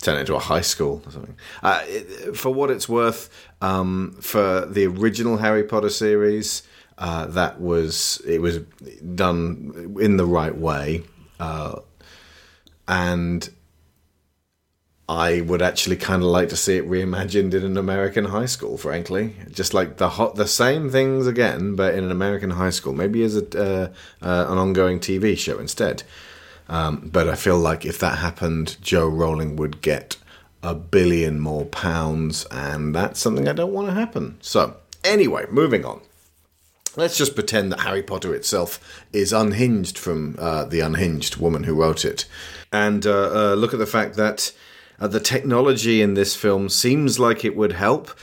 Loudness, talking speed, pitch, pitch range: -21 LUFS, 170 wpm, 90 Hz, 80-105 Hz